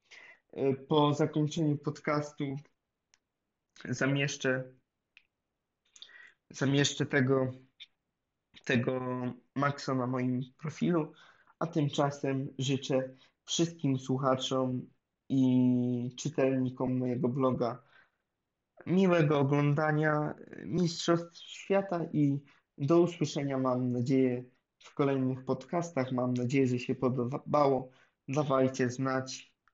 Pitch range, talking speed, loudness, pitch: 130-150 Hz, 80 wpm, -31 LUFS, 135 Hz